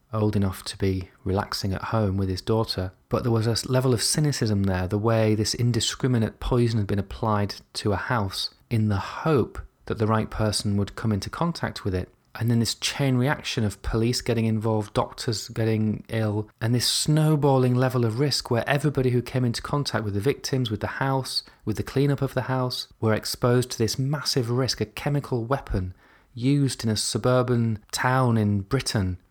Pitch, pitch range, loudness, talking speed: 115 Hz, 105-130 Hz, -25 LUFS, 190 wpm